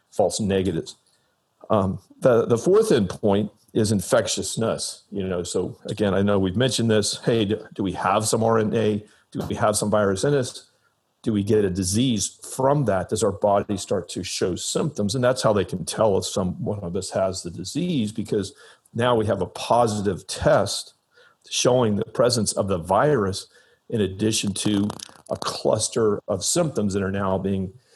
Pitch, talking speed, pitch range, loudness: 105 Hz, 180 wpm, 100-115 Hz, -23 LUFS